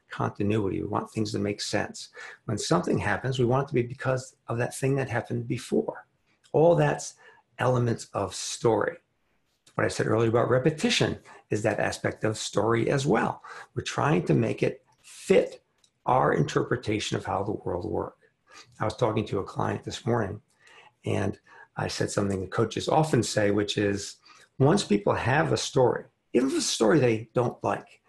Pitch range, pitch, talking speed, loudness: 105-130 Hz, 115 Hz, 180 wpm, -27 LUFS